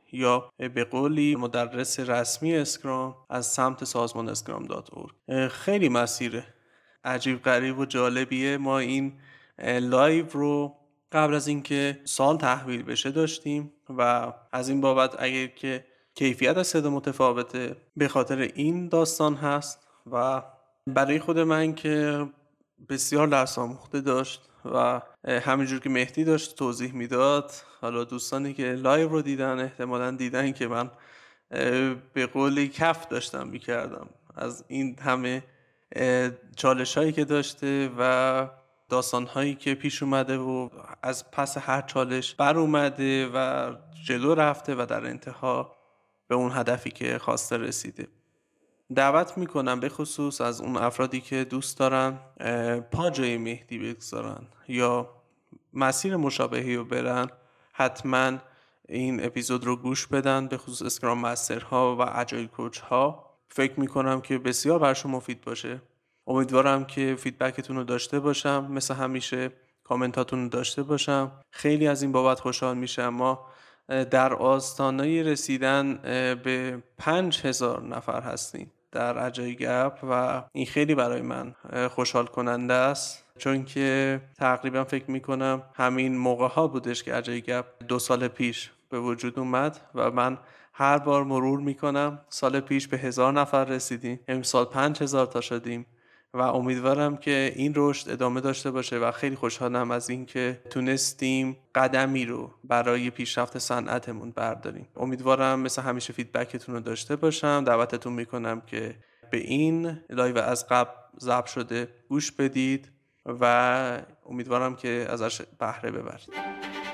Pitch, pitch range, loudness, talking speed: 130 Hz, 125-140 Hz, -27 LUFS, 135 wpm